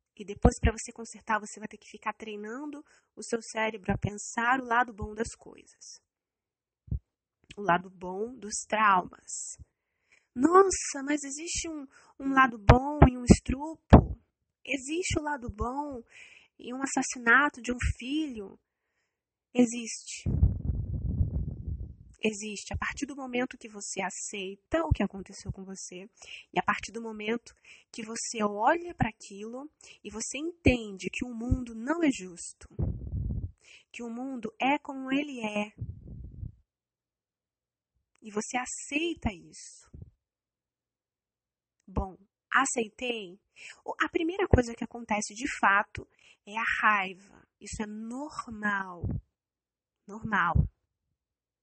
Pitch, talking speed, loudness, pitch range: 235 Hz, 125 wpm, -30 LUFS, 210-280 Hz